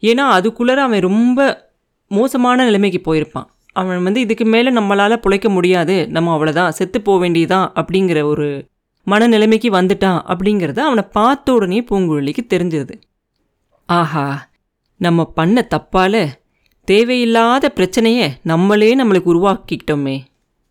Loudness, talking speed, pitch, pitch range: -14 LUFS, 110 wpm, 190 Hz, 165-225 Hz